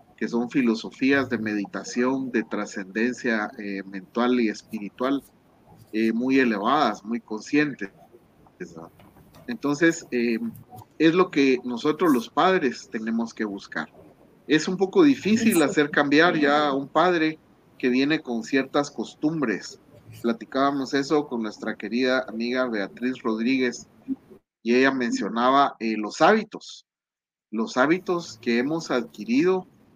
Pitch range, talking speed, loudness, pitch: 115-150 Hz, 120 wpm, -24 LUFS, 125 Hz